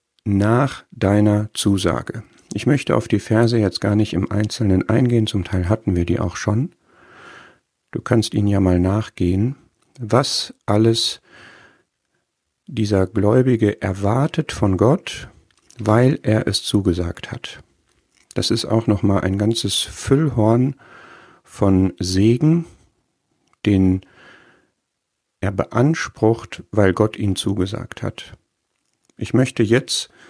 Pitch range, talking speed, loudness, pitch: 100-120 Hz, 120 wpm, -19 LUFS, 110 Hz